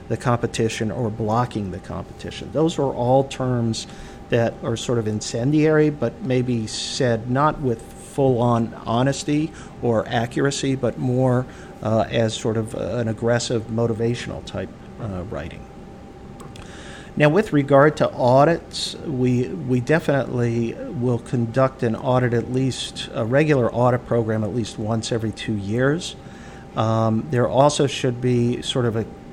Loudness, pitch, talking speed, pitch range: -21 LUFS, 120 Hz, 140 wpm, 115-135 Hz